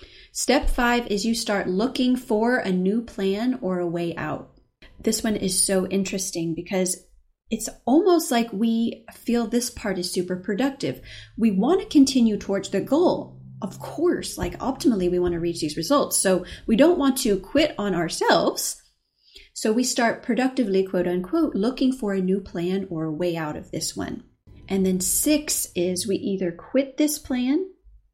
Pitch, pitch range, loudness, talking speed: 210 Hz, 185-255 Hz, -23 LUFS, 175 wpm